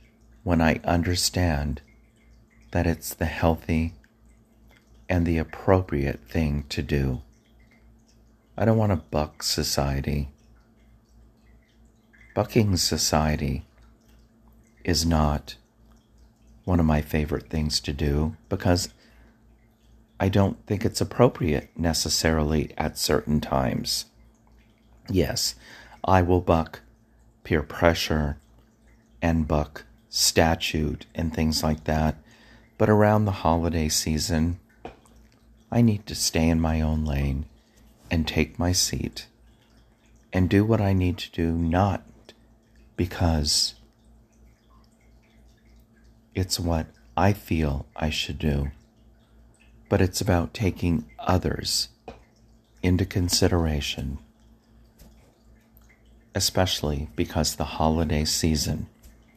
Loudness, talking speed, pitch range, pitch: -25 LUFS, 100 wpm, 80-110 Hz, 90 Hz